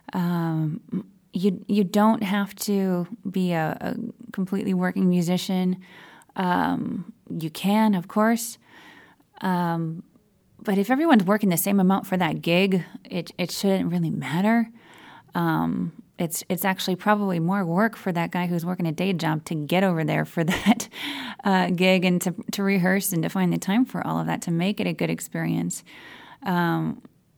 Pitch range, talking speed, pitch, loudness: 175-205 Hz, 165 wpm, 190 Hz, -24 LUFS